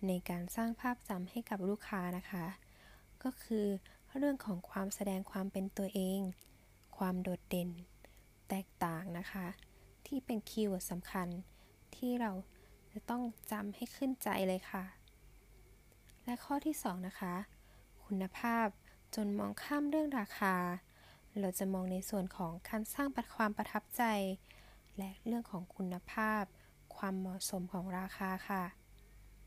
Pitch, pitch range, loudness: 195 Hz, 185-220 Hz, -40 LUFS